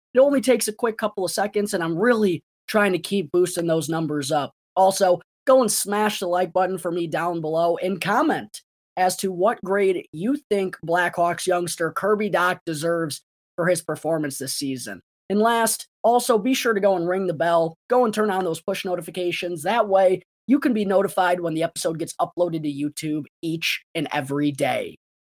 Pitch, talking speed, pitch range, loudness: 180 Hz, 195 wpm, 165-205 Hz, -22 LUFS